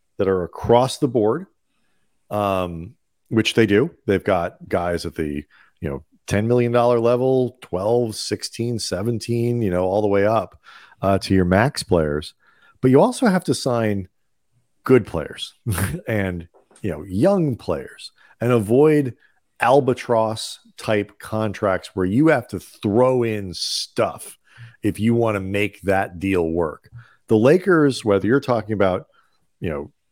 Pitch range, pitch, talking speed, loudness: 95-120 Hz, 110 Hz, 145 wpm, -20 LUFS